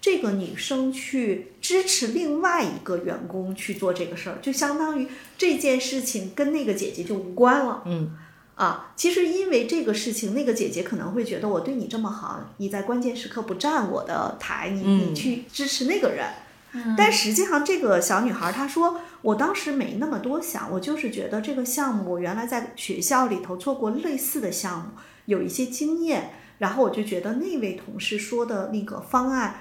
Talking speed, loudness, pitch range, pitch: 290 characters per minute, -25 LUFS, 200-285 Hz, 240 Hz